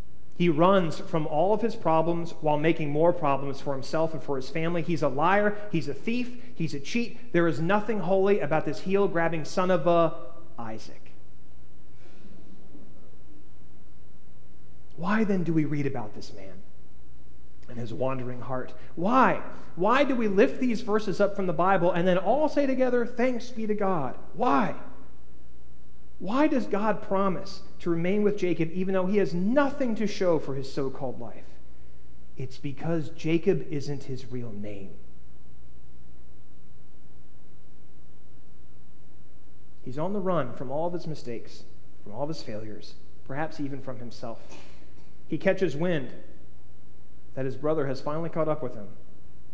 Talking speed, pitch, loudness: 155 wpm, 140 Hz, -27 LUFS